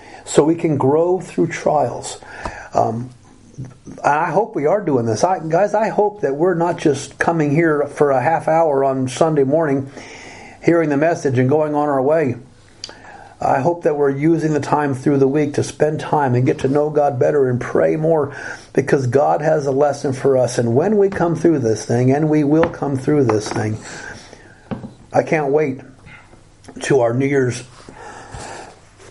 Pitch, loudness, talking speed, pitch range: 145 Hz, -17 LUFS, 180 wpm, 125-160 Hz